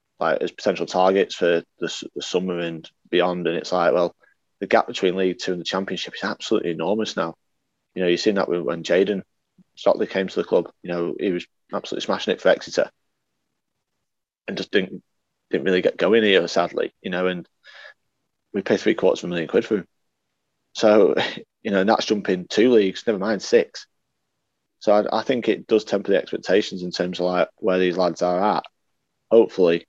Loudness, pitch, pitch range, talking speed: -22 LUFS, 90 Hz, 90-105 Hz, 195 wpm